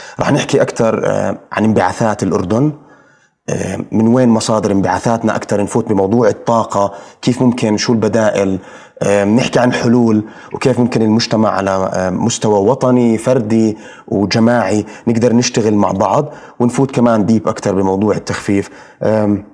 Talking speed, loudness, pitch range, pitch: 120 wpm, -14 LUFS, 105-120 Hz, 110 Hz